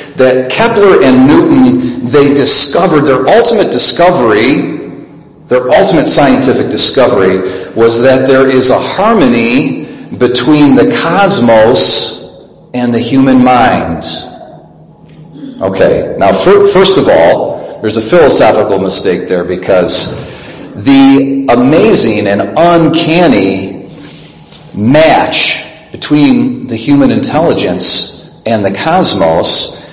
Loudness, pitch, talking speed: -7 LUFS, 150 Hz, 100 wpm